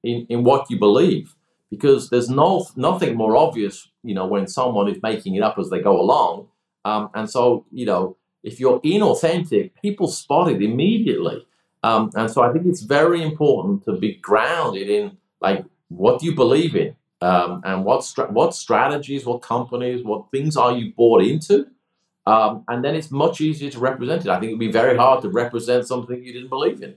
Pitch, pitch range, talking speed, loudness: 125 Hz, 115-155 Hz, 200 wpm, -19 LUFS